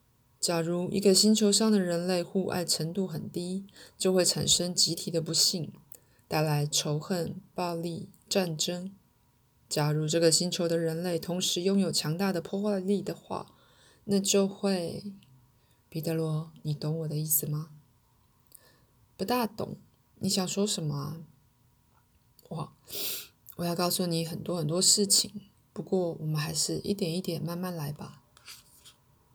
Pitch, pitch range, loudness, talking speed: 170 Hz, 155-190 Hz, -28 LUFS, 210 characters per minute